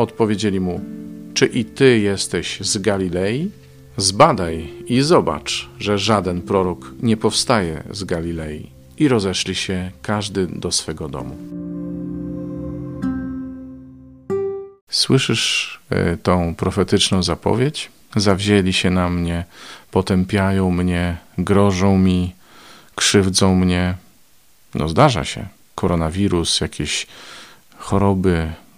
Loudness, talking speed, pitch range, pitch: -19 LUFS, 95 wpm, 85-105 Hz, 95 Hz